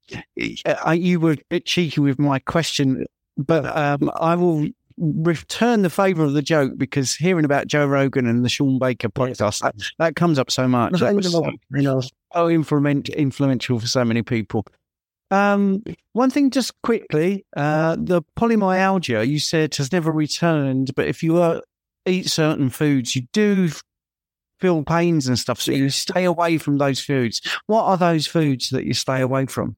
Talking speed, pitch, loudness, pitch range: 165 wpm, 150 Hz, -20 LUFS, 135-175 Hz